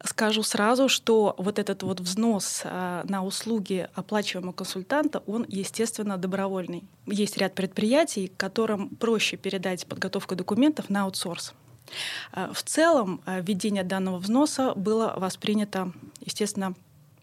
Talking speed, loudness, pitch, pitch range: 110 wpm, -27 LUFS, 195 Hz, 185-220 Hz